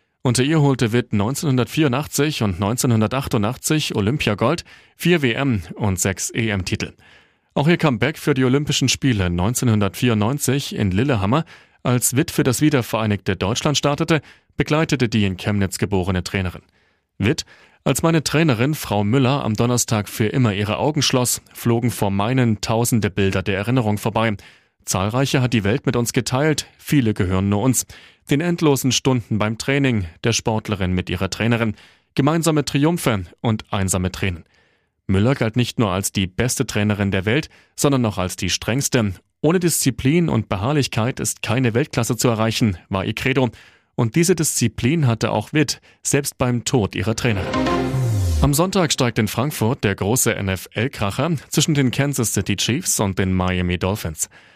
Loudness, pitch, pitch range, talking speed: -20 LUFS, 120 Hz, 105-135 Hz, 155 wpm